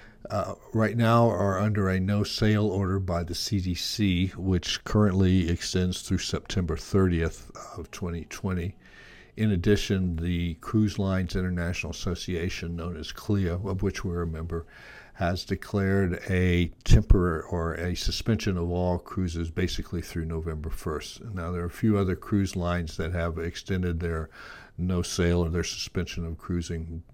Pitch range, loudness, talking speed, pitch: 85-100 Hz, -28 LUFS, 145 wpm, 90 Hz